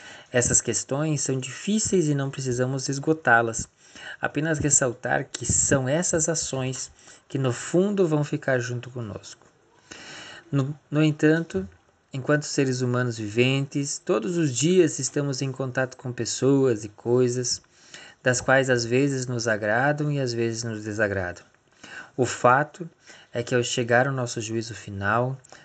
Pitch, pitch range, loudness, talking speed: 130 Hz, 120-150 Hz, -24 LUFS, 140 wpm